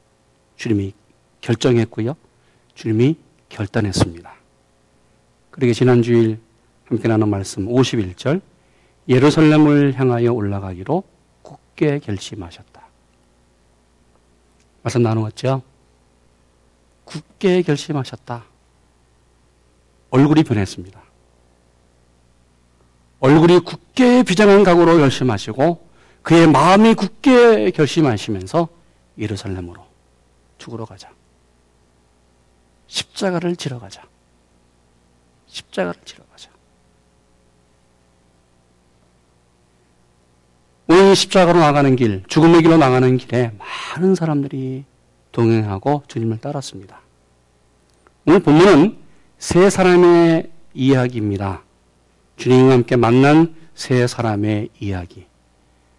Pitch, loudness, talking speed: 100 Hz, -15 LUFS, 210 characters per minute